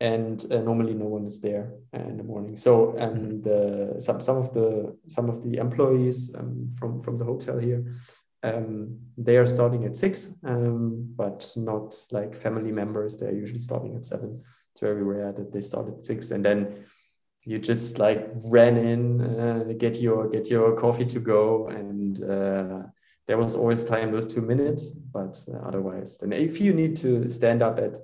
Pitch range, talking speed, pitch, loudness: 105-120 Hz, 185 wpm, 115 Hz, -26 LUFS